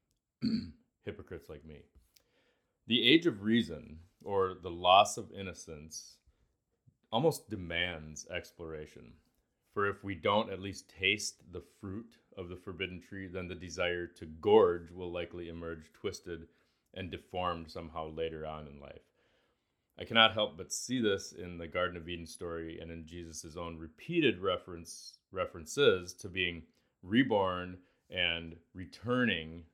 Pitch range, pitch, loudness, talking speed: 80-95 Hz, 85 Hz, -33 LUFS, 135 wpm